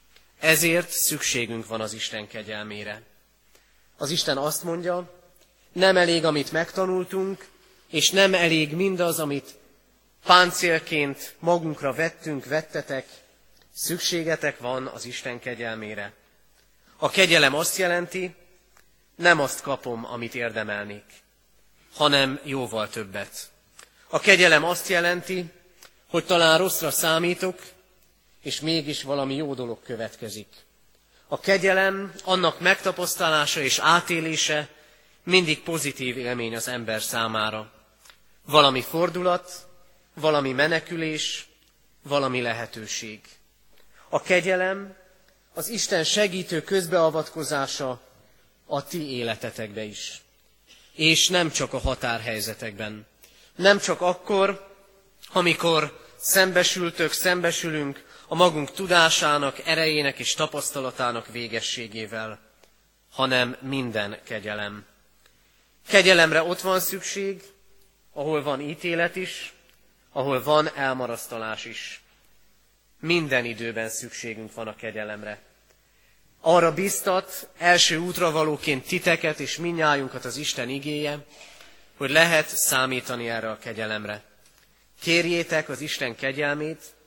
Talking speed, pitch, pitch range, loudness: 100 wpm, 150 Hz, 120-175 Hz, -23 LUFS